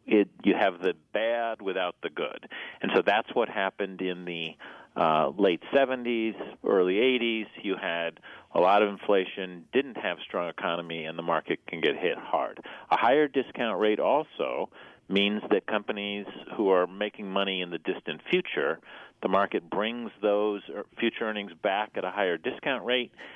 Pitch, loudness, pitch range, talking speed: 105 Hz, -28 LUFS, 95-115 Hz, 170 wpm